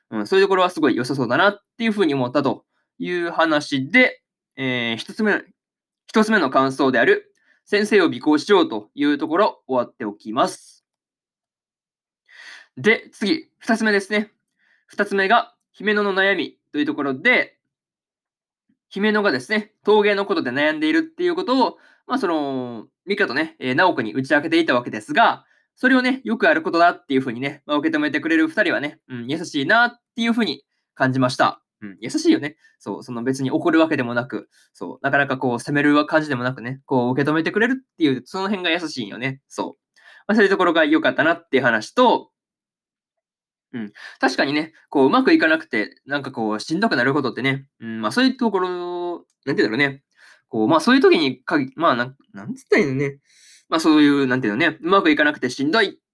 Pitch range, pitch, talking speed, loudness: 135-220 Hz, 170 Hz, 400 characters per minute, -20 LUFS